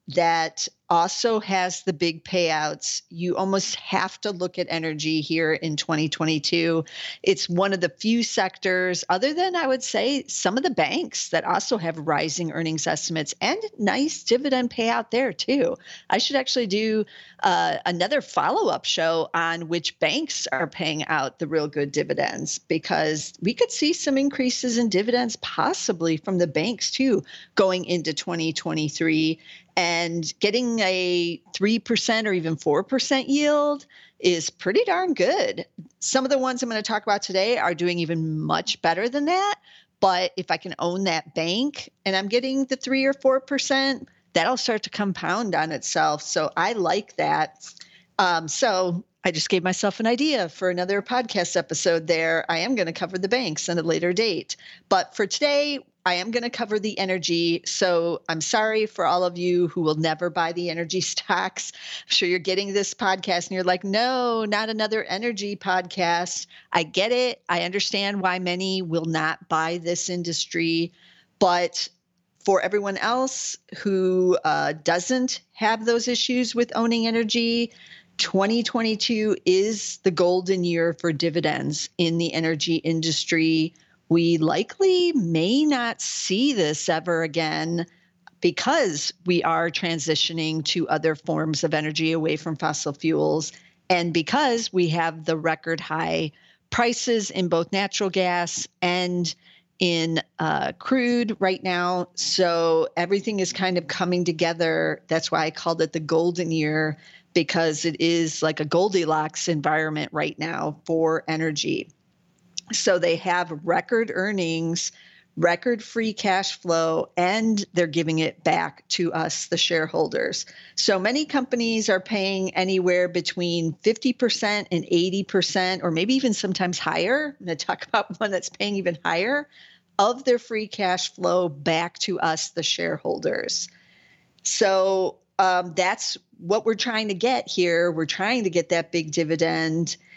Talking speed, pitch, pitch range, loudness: 155 wpm, 180 Hz, 165-220 Hz, -23 LUFS